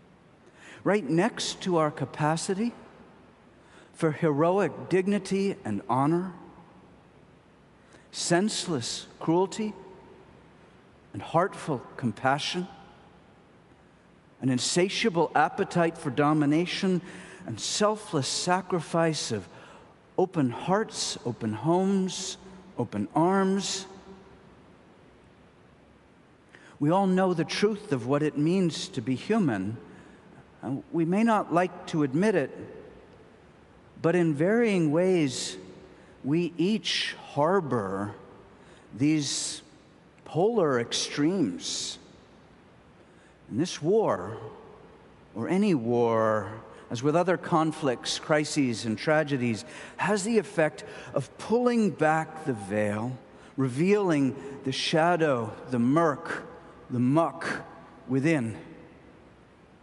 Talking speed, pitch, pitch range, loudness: 90 wpm, 160 Hz, 130-185 Hz, -27 LUFS